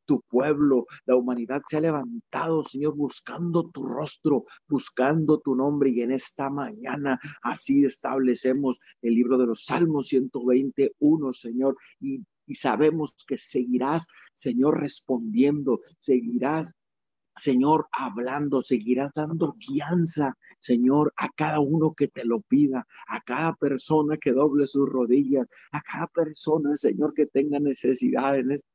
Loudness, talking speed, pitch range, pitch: -25 LUFS, 135 wpm, 130-155 Hz, 140 Hz